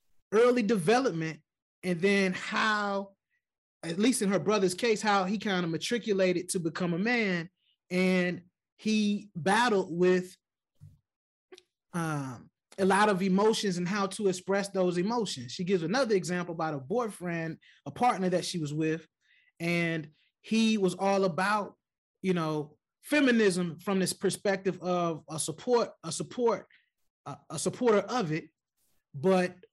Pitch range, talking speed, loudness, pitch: 170-210 Hz, 140 wpm, -29 LUFS, 190 Hz